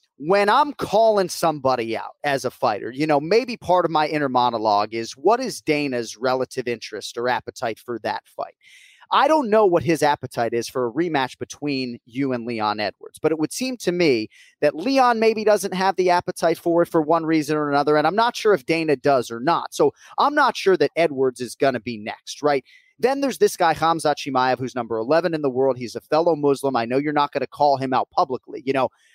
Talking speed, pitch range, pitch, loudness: 230 wpm, 130-185 Hz, 150 Hz, -21 LUFS